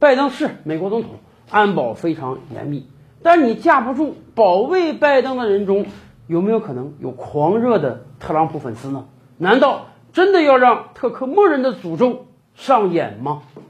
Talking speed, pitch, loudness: 245 characters per minute, 200 Hz, -17 LUFS